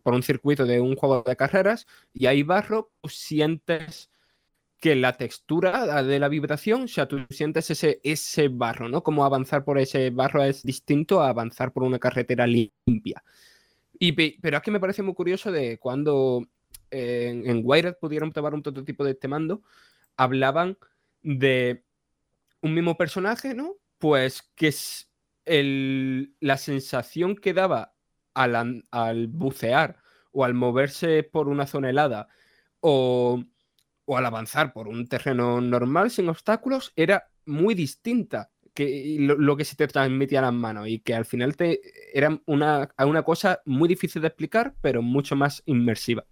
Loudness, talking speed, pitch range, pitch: -24 LUFS, 160 wpm, 130-160 Hz, 140 Hz